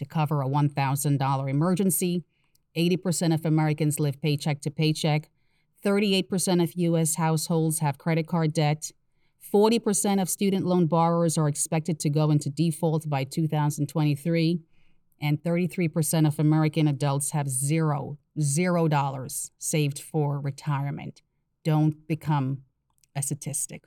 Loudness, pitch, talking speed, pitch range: -25 LUFS, 155 Hz, 125 wpm, 145-165 Hz